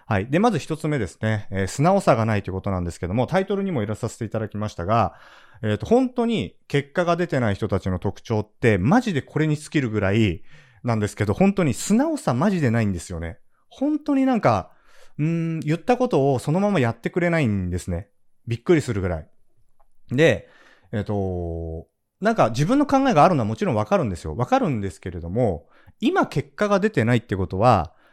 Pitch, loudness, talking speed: 120 Hz, -22 LUFS, 420 characters per minute